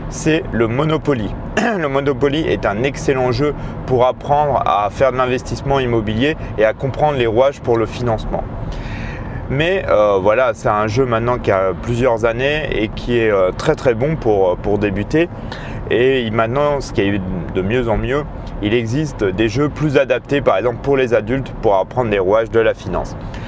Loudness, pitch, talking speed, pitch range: -17 LUFS, 125 Hz, 185 wpm, 110-140 Hz